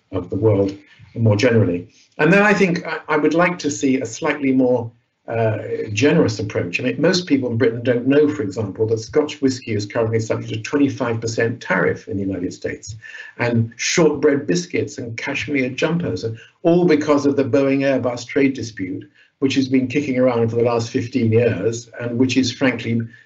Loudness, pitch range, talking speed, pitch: -19 LUFS, 115-145 Hz, 185 wpm, 125 Hz